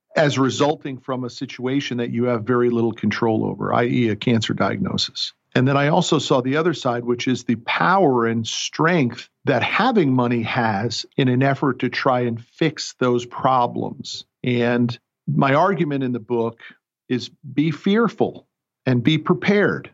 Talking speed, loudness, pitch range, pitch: 165 wpm, -20 LUFS, 120-140 Hz, 125 Hz